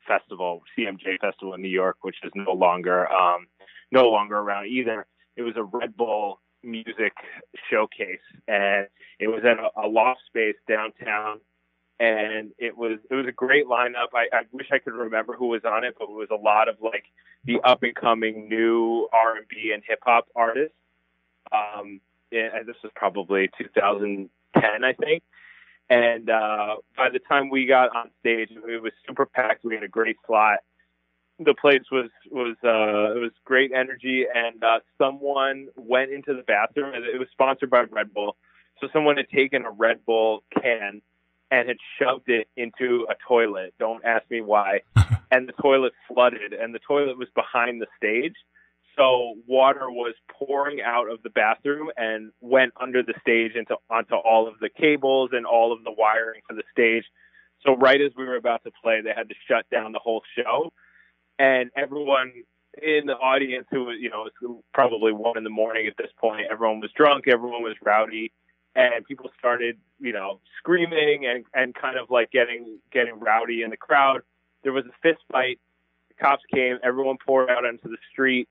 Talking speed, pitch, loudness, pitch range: 185 wpm, 115 Hz, -23 LUFS, 110-130 Hz